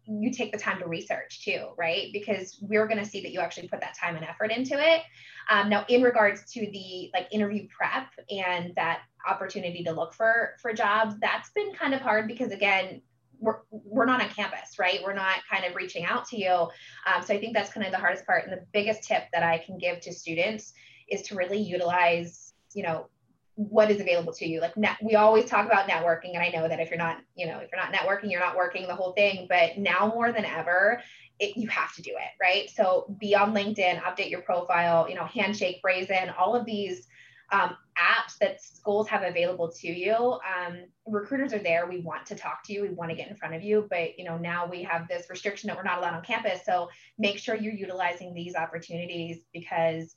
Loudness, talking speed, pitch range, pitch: -27 LUFS, 230 wpm, 175-215 Hz, 190 Hz